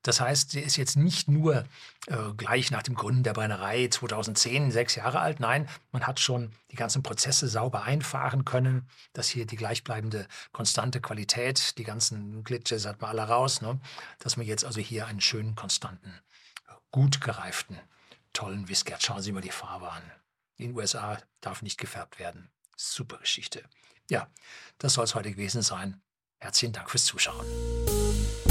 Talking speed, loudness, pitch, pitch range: 170 wpm, -28 LUFS, 115 Hz, 110-130 Hz